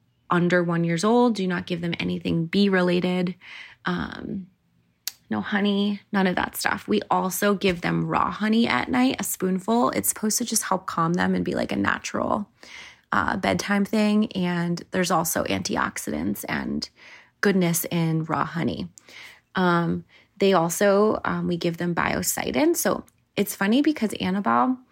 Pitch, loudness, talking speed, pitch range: 185 Hz, -24 LUFS, 155 wpm, 170-210 Hz